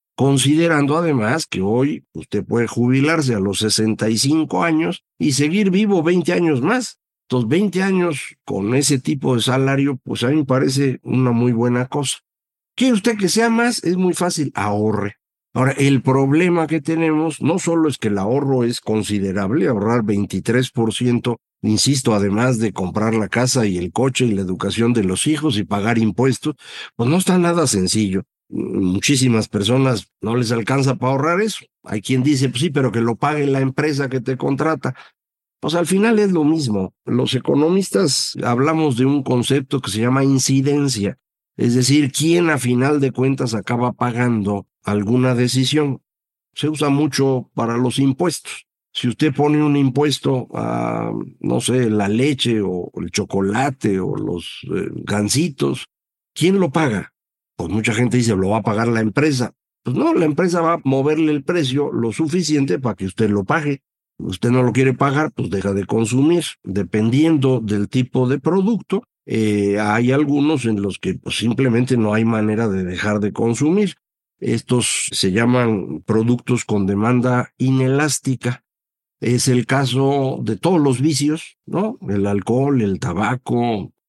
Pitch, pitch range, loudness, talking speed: 130 Hz, 110-150 Hz, -18 LUFS, 165 wpm